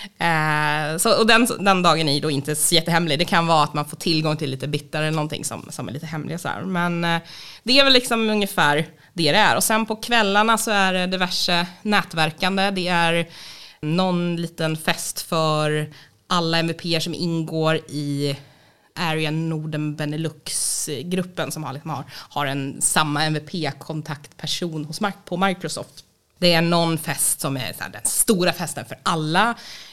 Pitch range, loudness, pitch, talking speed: 150-180 Hz, -21 LUFS, 165 Hz, 170 wpm